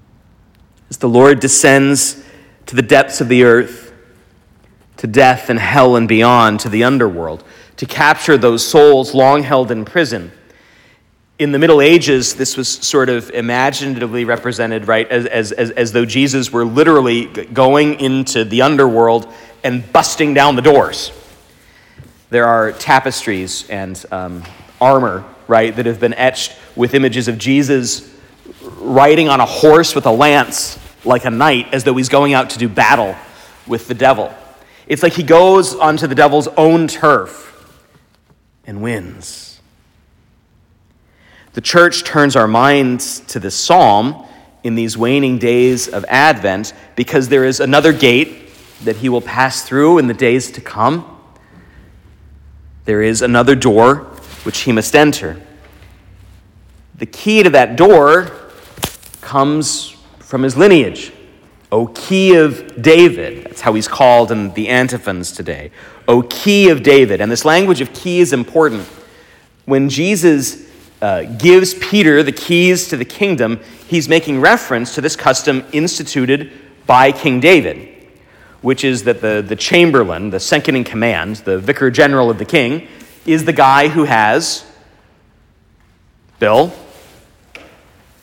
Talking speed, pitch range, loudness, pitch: 145 wpm, 115-140 Hz, -12 LUFS, 130 Hz